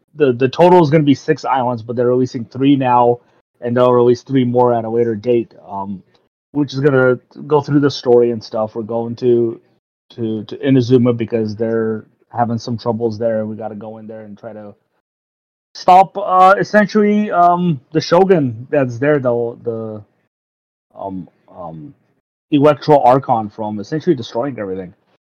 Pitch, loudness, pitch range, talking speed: 120 Hz, -15 LUFS, 110-145 Hz, 175 wpm